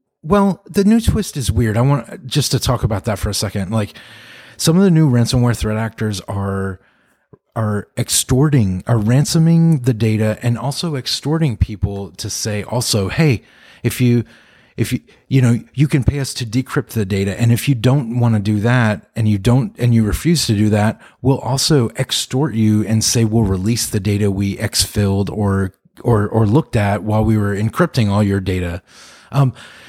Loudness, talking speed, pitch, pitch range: -17 LUFS, 195 wpm, 115 Hz, 105-135 Hz